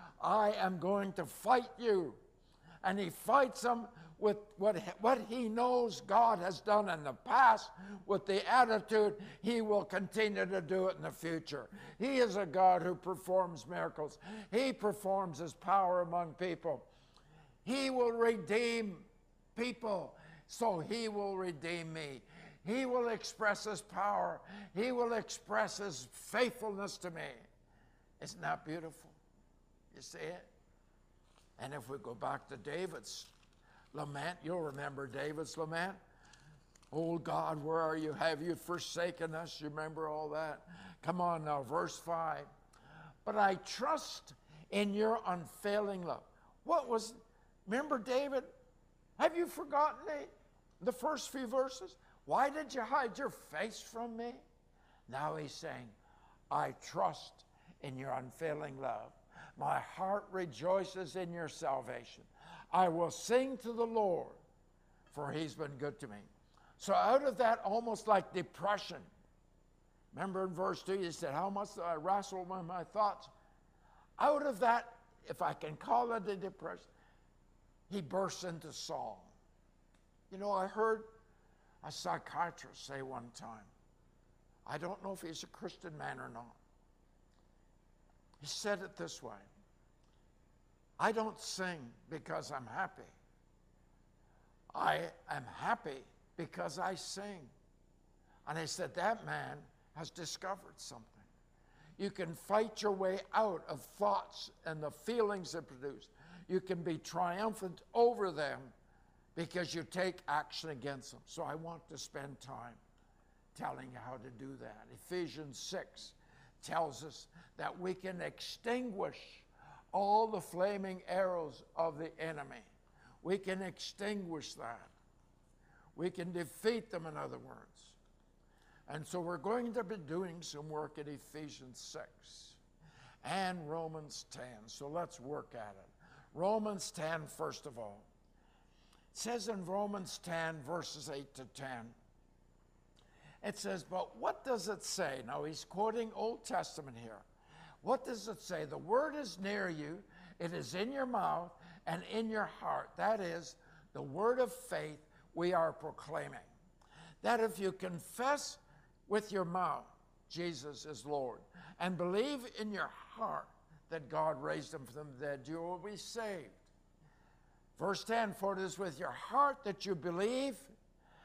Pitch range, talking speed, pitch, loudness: 155-210 Hz, 145 wpm, 180 Hz, -38 LUFS